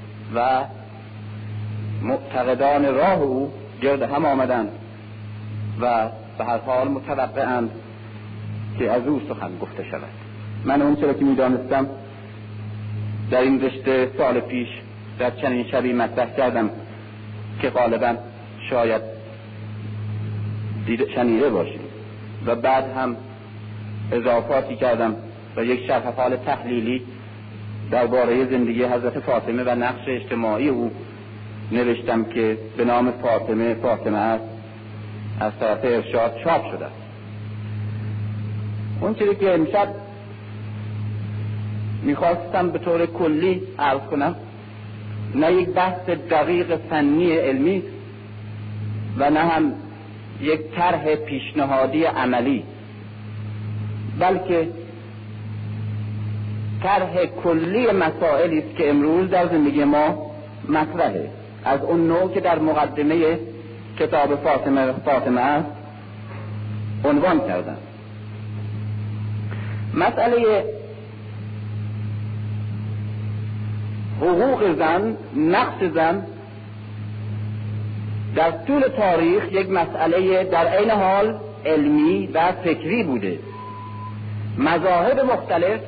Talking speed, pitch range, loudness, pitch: 95 wpm, 105-140 Hz, -22 LUFS, 110 Hz